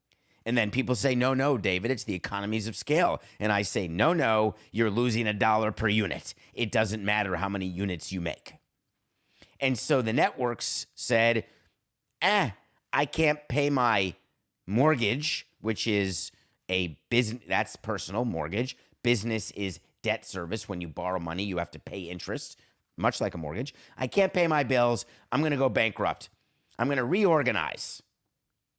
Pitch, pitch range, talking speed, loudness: 110 Hz, 95-125 Hz, 165 wpm, -28 LUFS